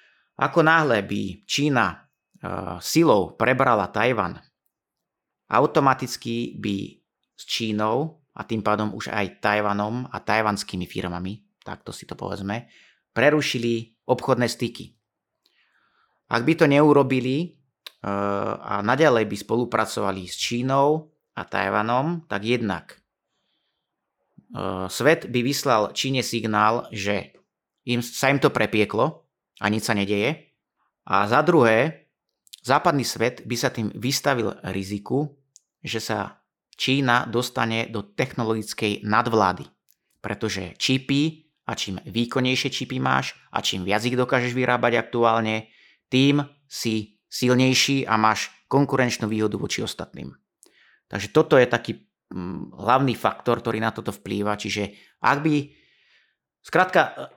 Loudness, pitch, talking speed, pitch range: -23 LUFS, 115 Hz, 120 wpm, 105-130 Hz